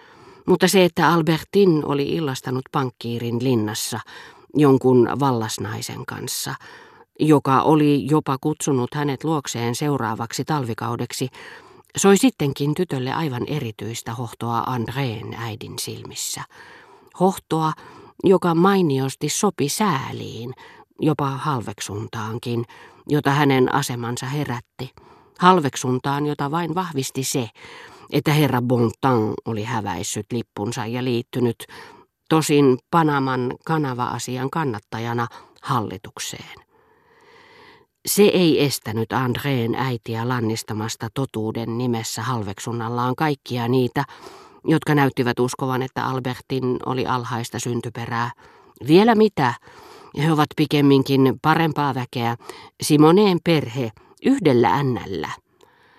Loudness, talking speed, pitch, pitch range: -21 LUFS, 95 wpm, 130 Hz, 120-155 Hz